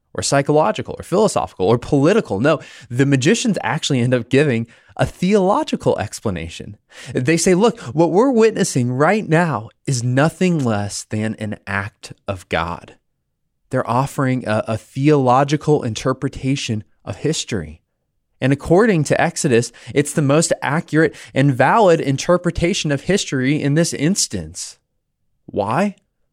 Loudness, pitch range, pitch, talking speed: -18 LUFS, 115-160 Hz, 140 Hz, 130 wpm